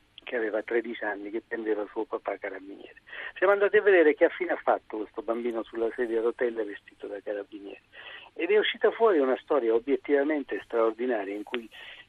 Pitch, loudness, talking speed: 120 Hz, -27 LUFS, 180 wpm